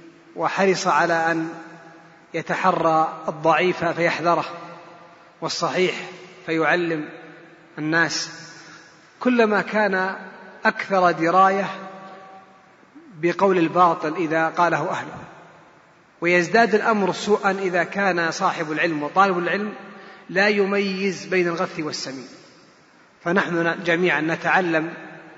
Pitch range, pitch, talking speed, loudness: 165-190 Hz, 175 Hz, 85 wpm, -21 LUFS